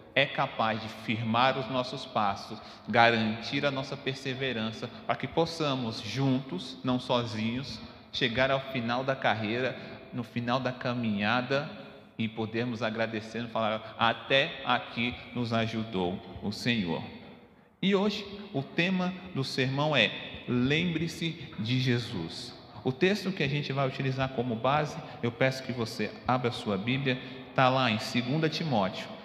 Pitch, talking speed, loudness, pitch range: 125 Hz, 140 wpm, -30 LUFS, 115-135 Hz